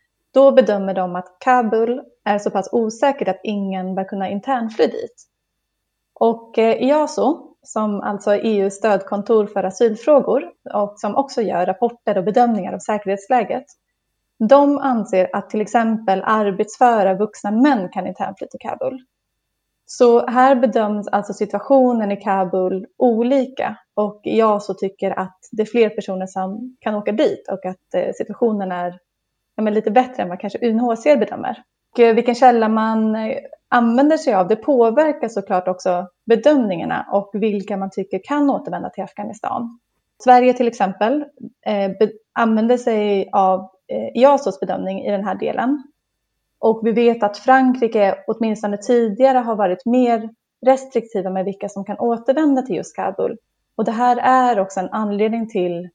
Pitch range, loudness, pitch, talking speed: 195-250 Hz, -18 LUFS, 220 Hz, 145 wpm